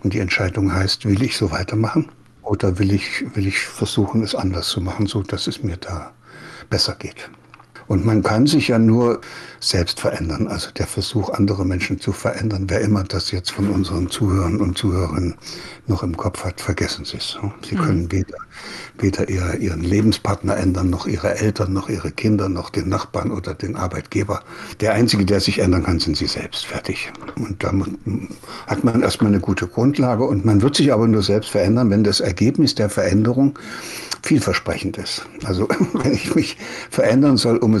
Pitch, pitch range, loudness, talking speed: 100 Hz, 95-110 Hz, -19 LUFS, 185 wpm